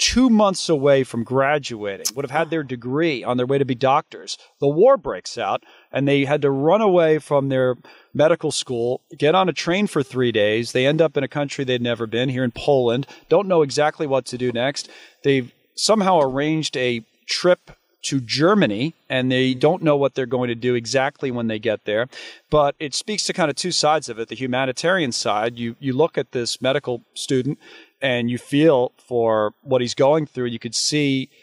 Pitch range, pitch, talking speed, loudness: 125-150 Hz, 135 Hz, 215 wpm, -20 LUFS